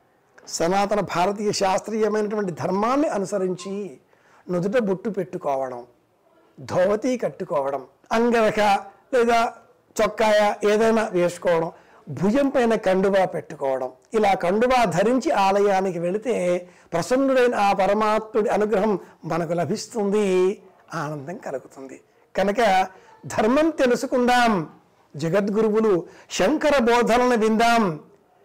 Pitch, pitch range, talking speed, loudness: 205 Hz, 180-230 Hz, 80 wpm, -22 LUFS